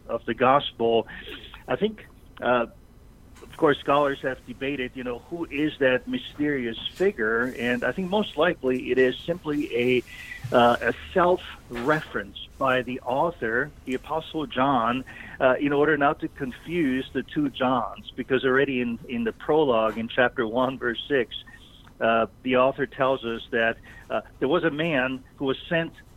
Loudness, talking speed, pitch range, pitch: -25 LUFS, 160 wpm, 125-150 Hz, 130 Hz